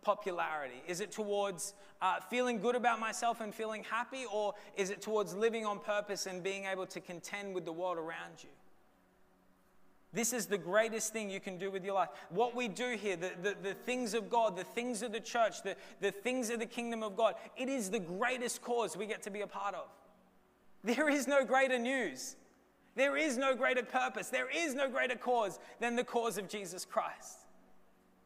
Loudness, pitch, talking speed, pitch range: -36 LUFS, 220 Hz, 205 wpm, 195-245 Hz